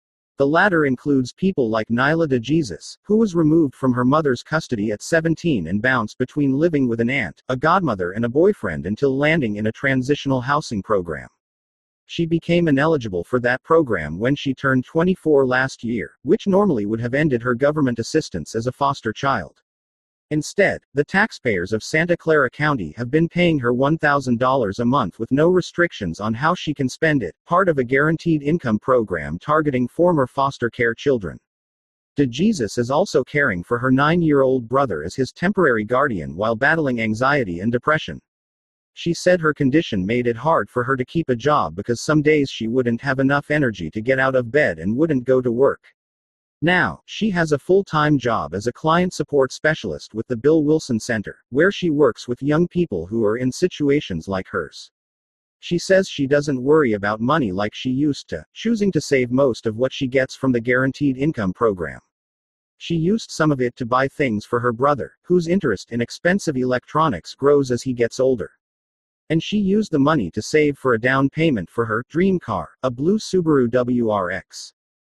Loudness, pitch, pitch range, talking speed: -20 LUFS, 135 Hz, 115-155 Hz, 190 wpm